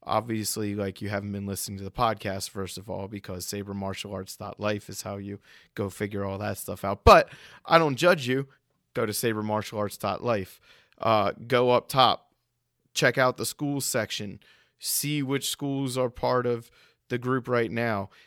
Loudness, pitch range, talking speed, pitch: -27 LUFS, 100-125 Hz, 185 wpm, 110 Hz